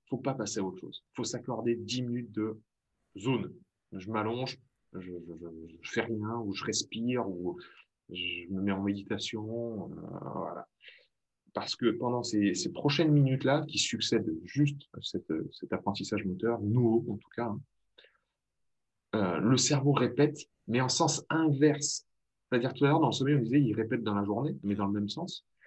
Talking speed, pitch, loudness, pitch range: 185 wpm, 115 Hz, -31 LUFS, 100-130 Hz